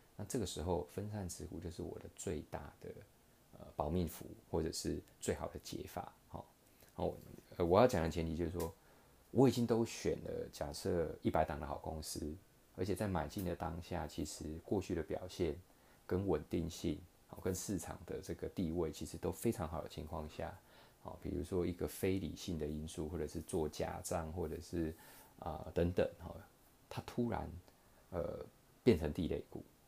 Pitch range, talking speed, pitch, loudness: 80-100 Hz, 255 characters per minute, 90 Hz, -40 LUFS